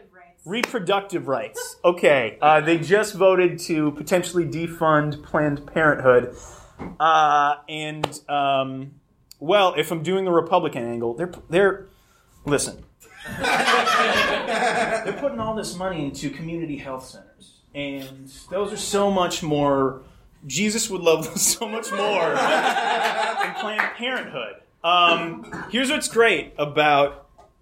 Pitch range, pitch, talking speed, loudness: 145-195 Hz, 165 Hz, 120 wpm, -21 LUFS